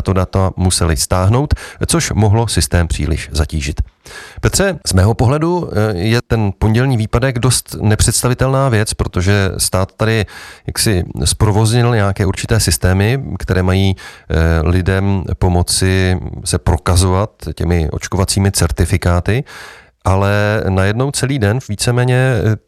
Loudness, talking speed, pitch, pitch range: -15 LUFS, 115 wpm, 100 Hz, 90-115 Hz